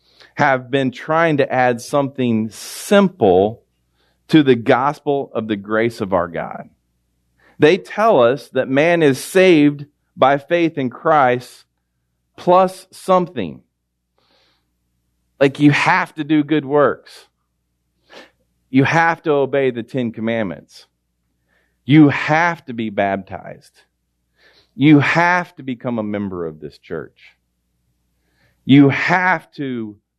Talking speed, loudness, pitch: 120 wpm, -16 LUFS, 125 Hz